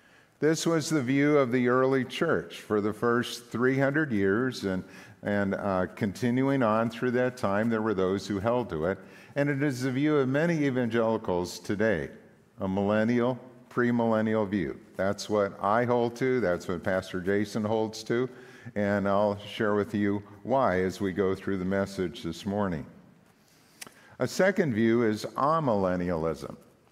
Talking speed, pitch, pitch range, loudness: 160 wpm, 110 Hz, 100-125 Hz, -28 LUFS